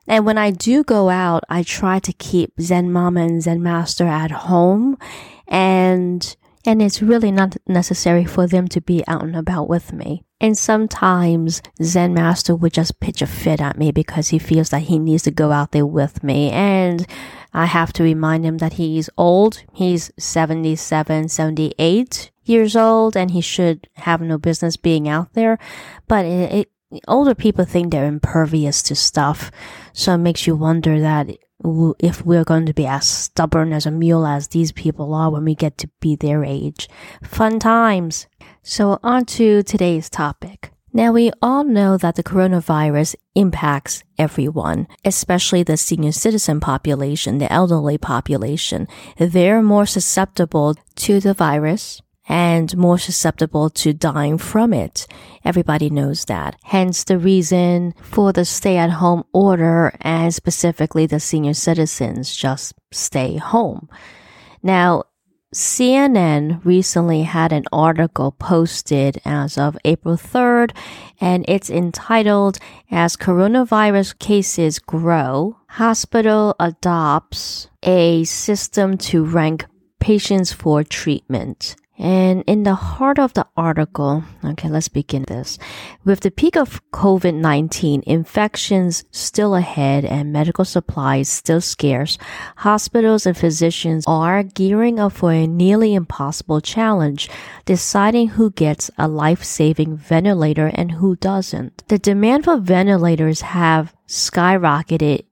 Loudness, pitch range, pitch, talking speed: -17 LUFS, 155-195 Hz, 170 Hz, 140 wpm